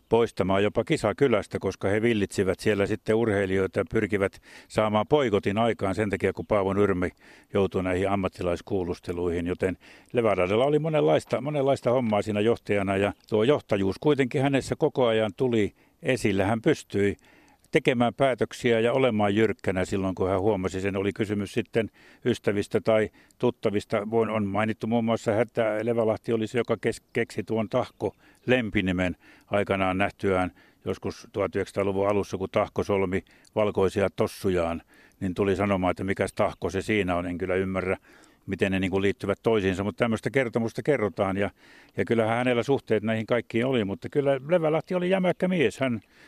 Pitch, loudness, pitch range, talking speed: 105 Hz, -26 LUFS, 95-115 Hz, 150 wpm